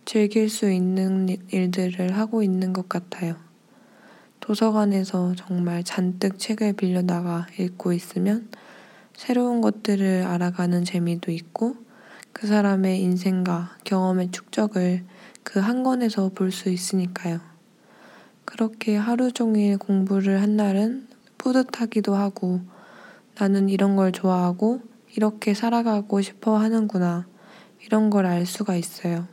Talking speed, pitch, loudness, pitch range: 260 characters per minute, 195 Hz, -23 LUFS, 180-220 Hz